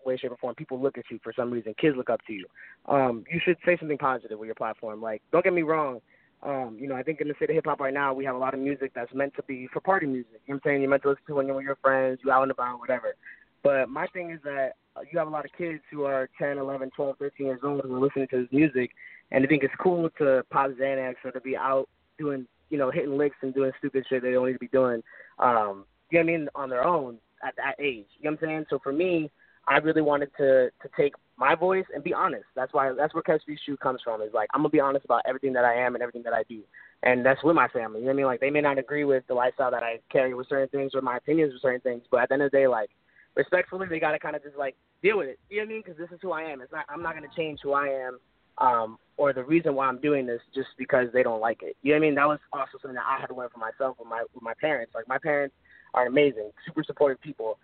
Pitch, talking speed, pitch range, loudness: 135 Hz, 305 wpm, 130-150 Hz, -27 LUFS